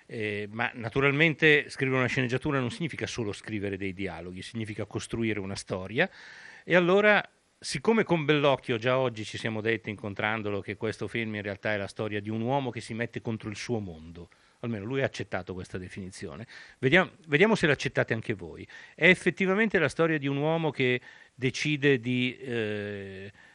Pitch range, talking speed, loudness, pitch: 105-140 Hz, 175 wpm, -28 LUFS, 120 Hz